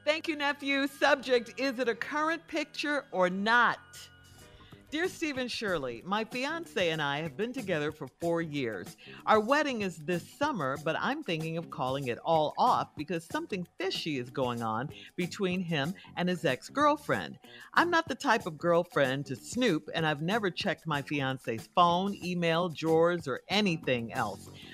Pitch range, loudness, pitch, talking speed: 150-250 Hz, -31 LUFS, 175 Hz, 165 wpm